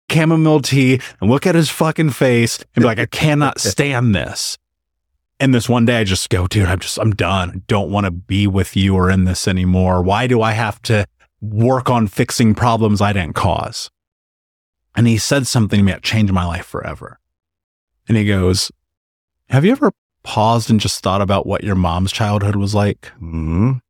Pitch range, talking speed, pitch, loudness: 90-120 Hz, 200 wpm, 100 Hz, -16 LUFS